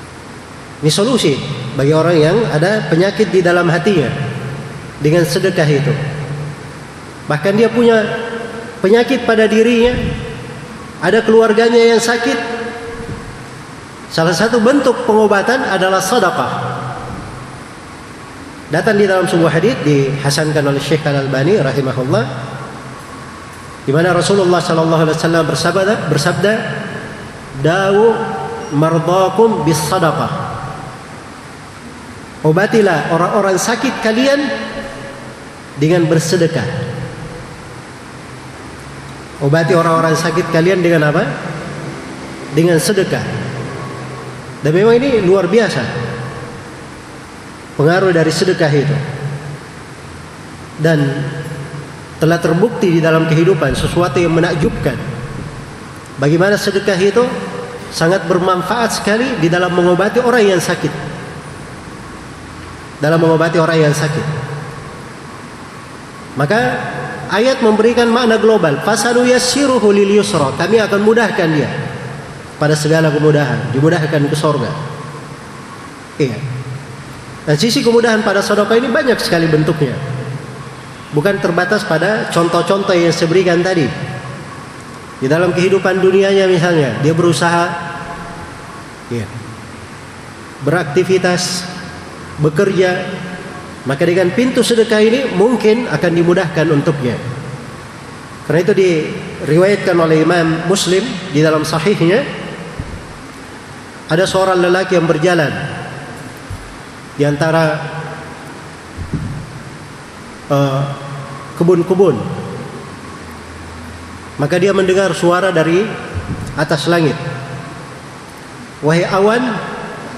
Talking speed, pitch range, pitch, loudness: 90 wpm, 145-195 Hz, 165 Hz, -13 LUFS